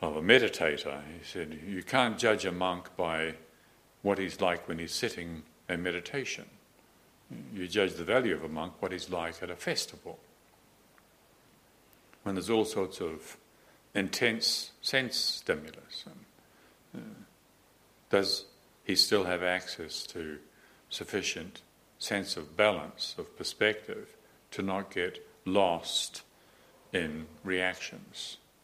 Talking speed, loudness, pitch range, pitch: 125 wpm, -32 LUFS, 80-95 Hz, 90 Hz